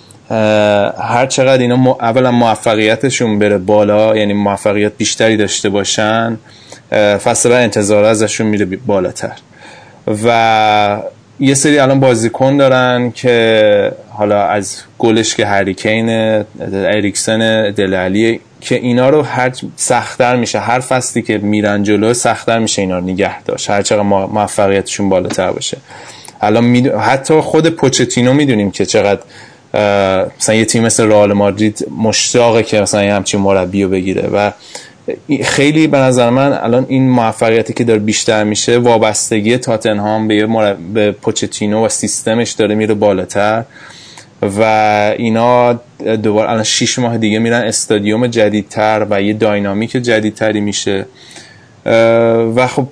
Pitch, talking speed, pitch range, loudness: 110 Hz, 130 wpm, 105-120 Hz, -12 LUFS